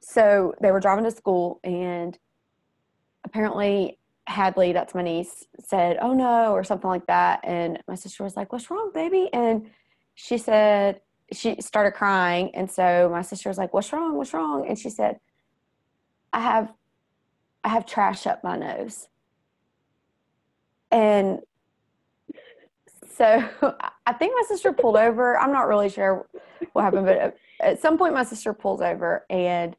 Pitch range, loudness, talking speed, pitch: 185-235 Hz, -23 LUFS, 155 wpm, 205 Hz